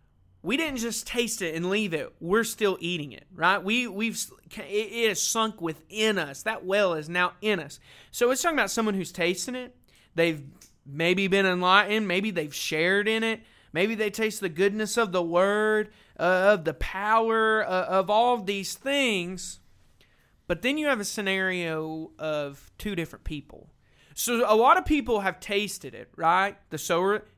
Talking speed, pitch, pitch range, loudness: 180 wpm, 195 Hz, 170-220 Hz, -26 LUFS